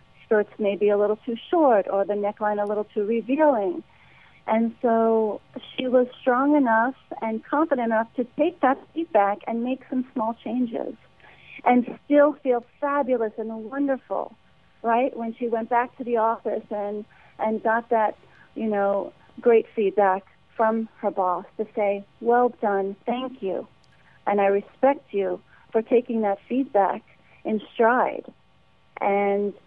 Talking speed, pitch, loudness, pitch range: 150 wpm, 225 Hz, -24 LUFS, 205-250 Hz